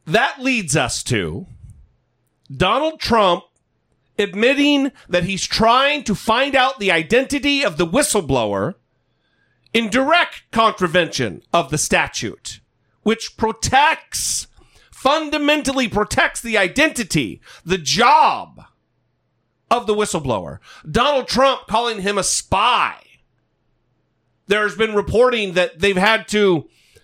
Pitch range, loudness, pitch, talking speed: 185-265 Hz, -17 LUFS, 220 Hz, 105 wpm